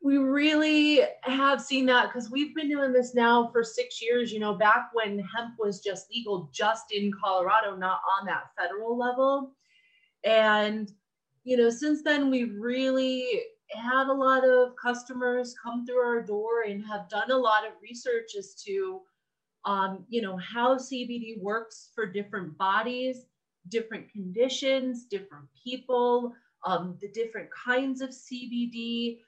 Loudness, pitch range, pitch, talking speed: -27 LUFS, 215-260 Hz, 240 Hz, 150 wpm